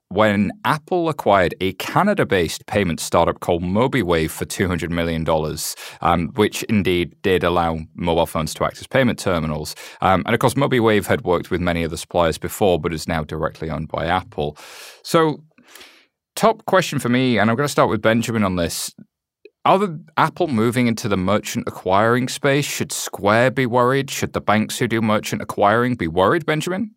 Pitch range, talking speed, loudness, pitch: 85-130 Hz, 185 wpm, -19 LUFS, 105 Hz